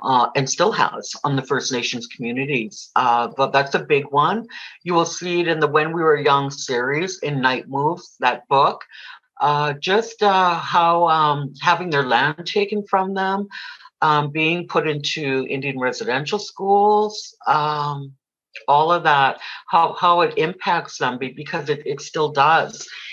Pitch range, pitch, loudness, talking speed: 140-185 Hz, 155 Hz, -19 LUFS, 165 wpm